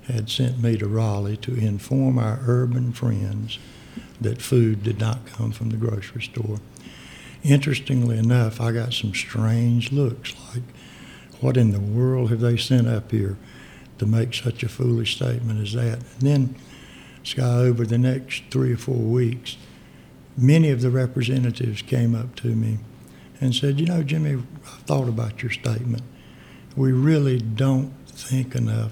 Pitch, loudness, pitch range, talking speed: 120 Hz, -22 LUFS, 110-130 Hz, 160 wpm